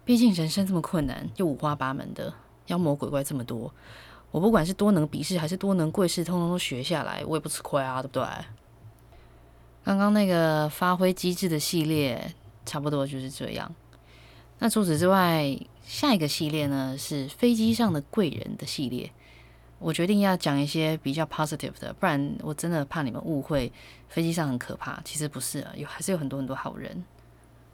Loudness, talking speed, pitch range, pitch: -27 LUFS, 300 characters per minute, 135-180 Hz, 155 Hz